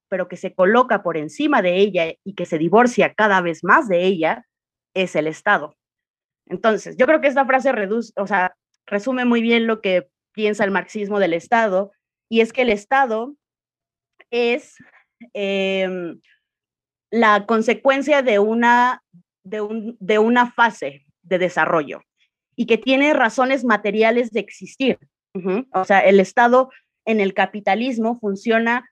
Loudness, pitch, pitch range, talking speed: -18 LUFS, 210 Hz, 185-240 Hz, 150 wpm